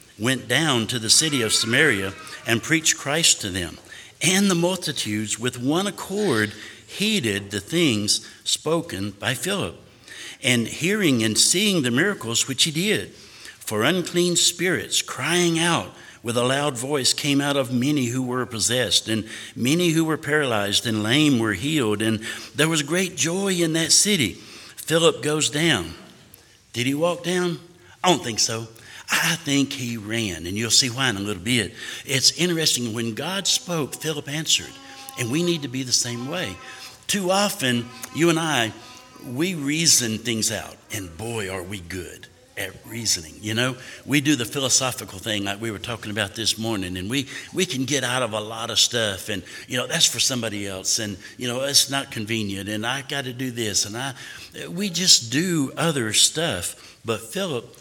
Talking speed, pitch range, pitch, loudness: 180 wpm, 110-160 Hz, 130 Hz, -21 LUFS